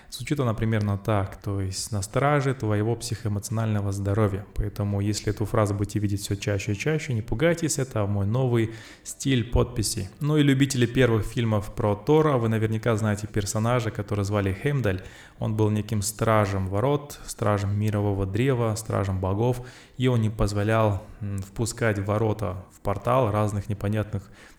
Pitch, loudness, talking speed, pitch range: 110 Hz, -25 LUFS, 150 wpm, 100-120 Hz